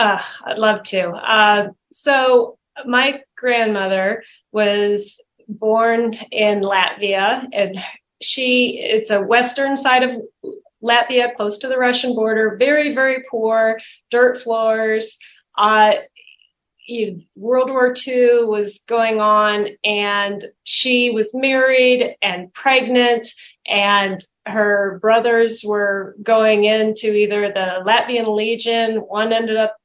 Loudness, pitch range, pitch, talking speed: -17 LUFS, 210-250 Hz, 225 Hz, 115 wpm